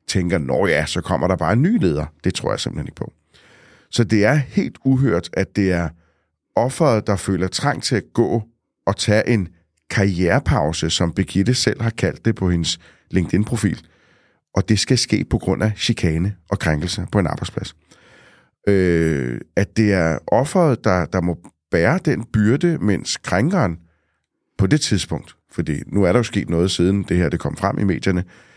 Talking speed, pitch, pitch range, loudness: 185 wpm, 95 Hz, 85-115 Hz, -19 LUFS